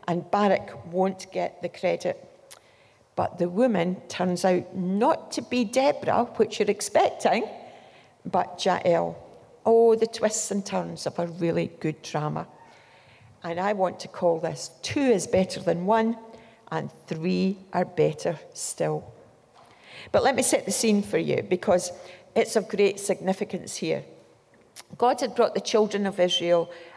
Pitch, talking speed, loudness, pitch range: 190 Hz, 150 wpm, -25 LUFS, 175-220 Hz